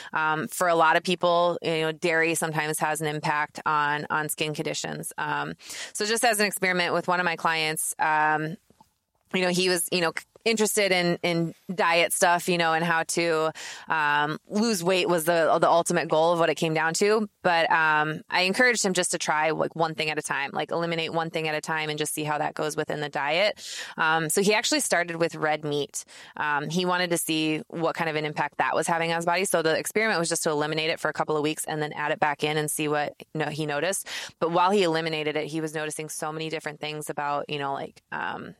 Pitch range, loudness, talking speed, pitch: 155-175 Hz, -25 LUFS, 245 wpm, 160 Hz